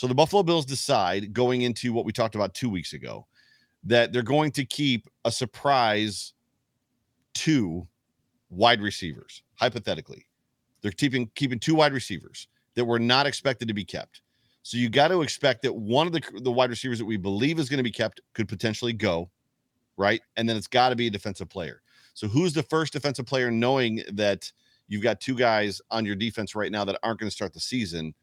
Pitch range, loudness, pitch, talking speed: 105-130 Hz, -26 LUFS, 120 Hz, 200 wpm